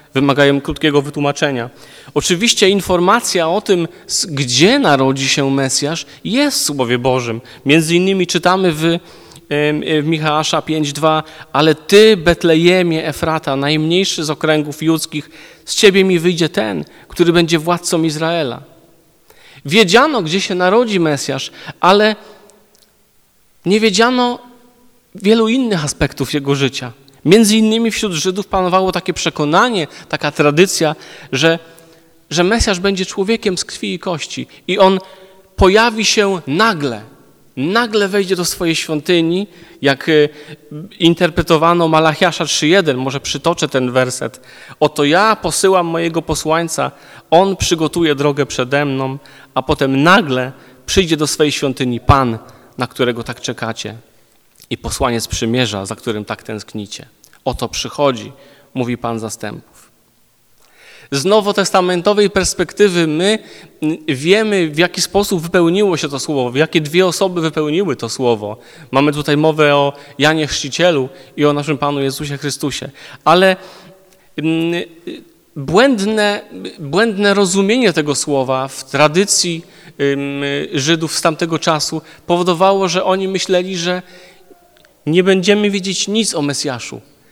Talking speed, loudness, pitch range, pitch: 120 wpm, -14 LUFS, 140-190 Hz, 160 Hz